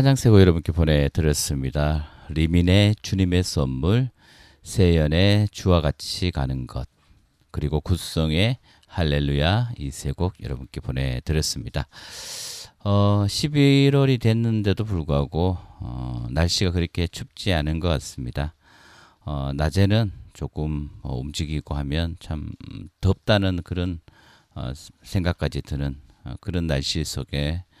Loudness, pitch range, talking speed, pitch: -23 LUFS, 75-100 Hz, 240 characters per minute, 85 Hz